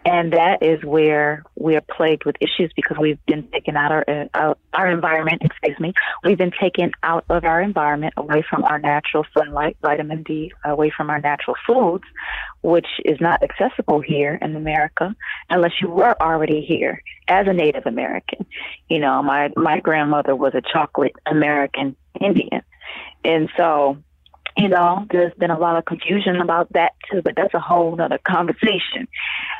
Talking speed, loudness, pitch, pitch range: 170 wpm, -19 LUFS, 155 Hz, 150-170 Hz